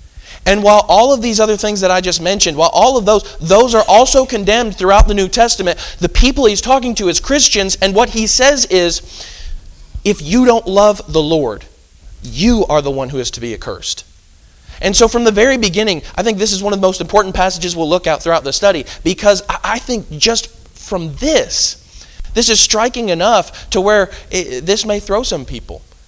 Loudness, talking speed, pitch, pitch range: -12 LUFS, 205 wpm, 190 Hz, 155-220 Hz